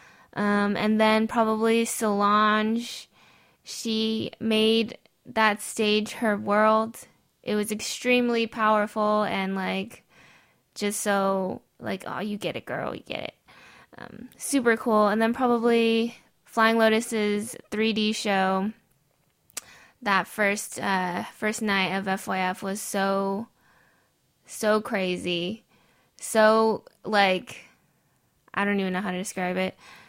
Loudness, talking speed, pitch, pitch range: -25 LUFS, 120 wpm, 215 Hz, 195-225 Hz